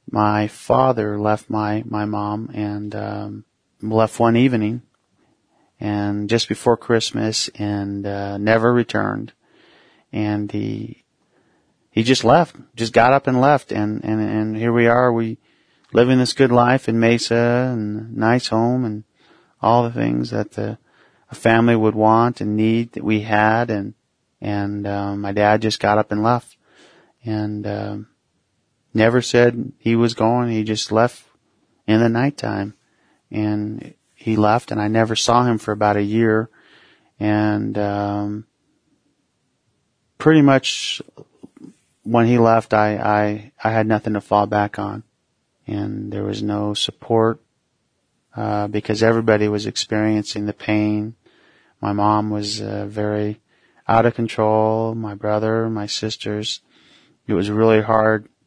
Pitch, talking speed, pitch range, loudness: 110 Hz, 145 wpm, 105-115 Hz, -19 LUFS